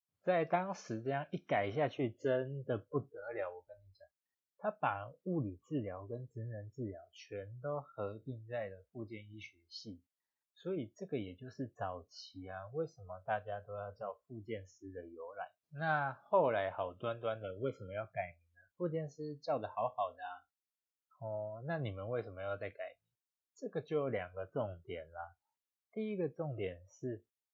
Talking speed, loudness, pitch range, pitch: 245 characters per minute, -41 LUFS, 95-140 Hz, 110 Hz